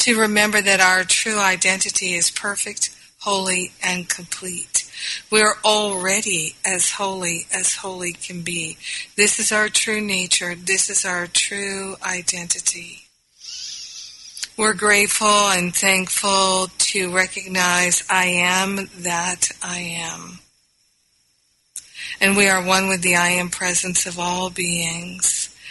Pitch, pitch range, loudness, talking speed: 185 Hz, 180-200 Hz, -18 LUFS, 125 wpm